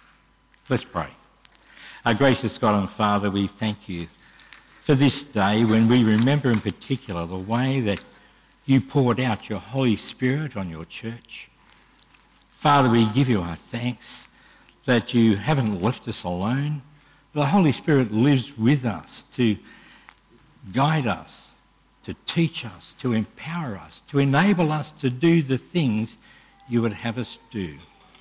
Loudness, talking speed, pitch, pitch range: -23 LUFS, 145 wpm, 120 Hz, 110-140 Hz